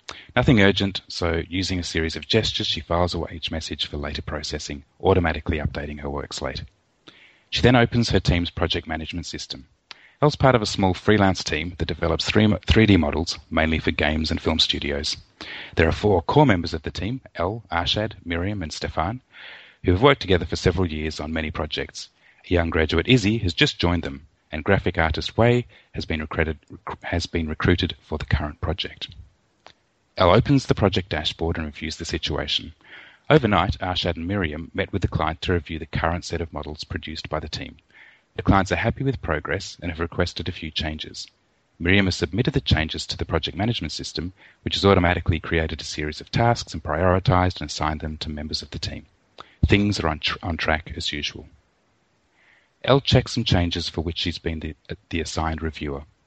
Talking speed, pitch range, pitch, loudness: 190 wpm, 80-100 Hz, 85 Hz, -23 LUFS